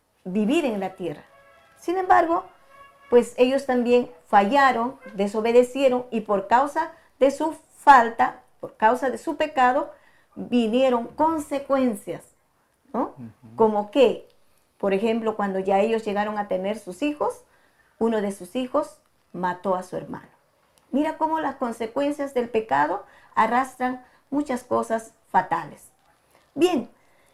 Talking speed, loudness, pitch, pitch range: 125 wpm, -23 LUFS, 250 Hz, 215-285 Hz